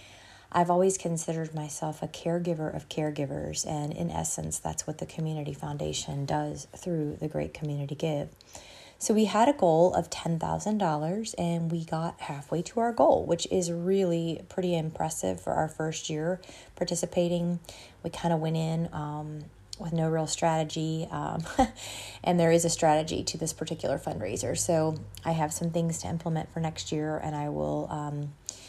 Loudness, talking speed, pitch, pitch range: -30 LUFS, 170 wpm, 160 Hz, 150-170 Hz